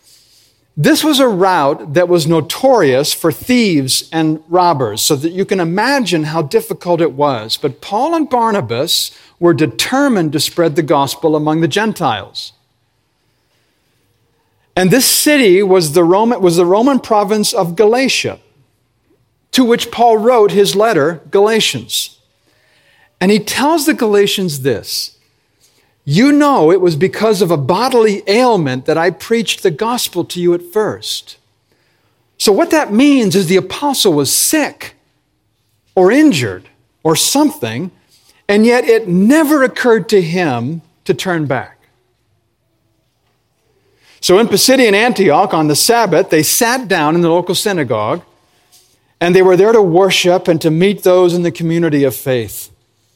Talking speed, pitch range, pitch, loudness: 145 wpm, 145-220 Hz, 180 Hz, -12 LUFS